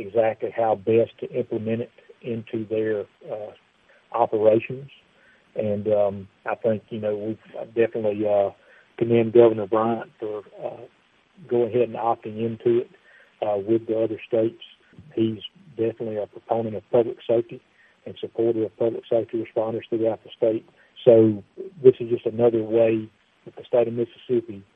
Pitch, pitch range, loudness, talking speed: 115 Hz, 110-115 Hz, -23 LUFS, 150 wpm